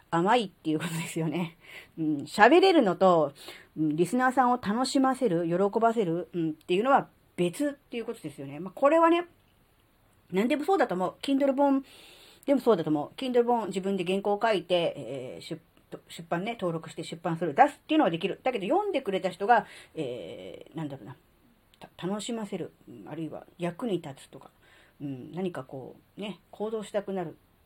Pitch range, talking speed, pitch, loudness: 165-250 Hz, 385 characters per minute, 190 Hz, -27 LUFS